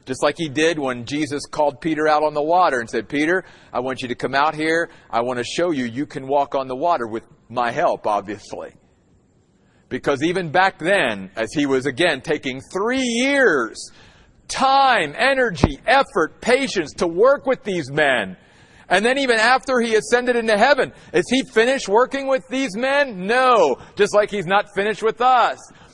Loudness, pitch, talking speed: -19 LUFS, 180 Hz, 185 wpm